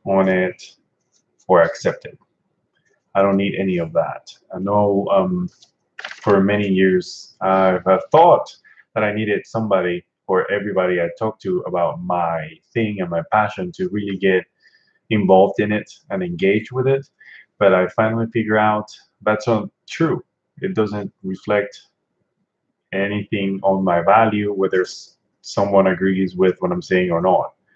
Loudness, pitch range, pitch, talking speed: -19 LUFS, 95-110 Hz, 100 Hz, 145 wpm